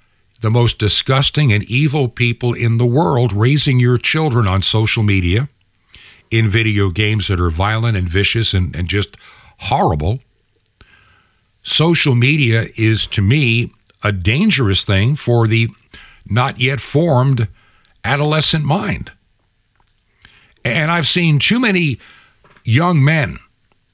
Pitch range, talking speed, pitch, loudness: 105-140 Hz, 125 wpm, 115 Hz, -15 LUFS